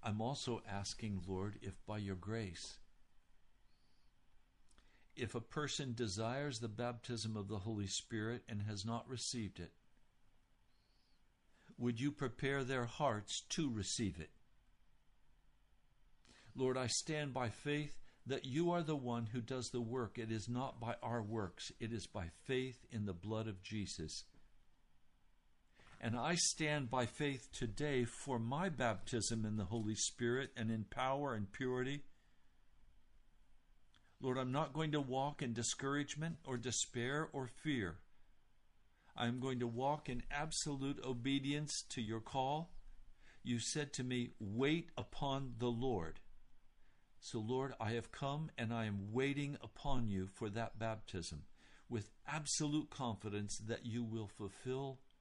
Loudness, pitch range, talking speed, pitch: -42 LUFS, 110-135 Hz, 140 wpm, 120 Hz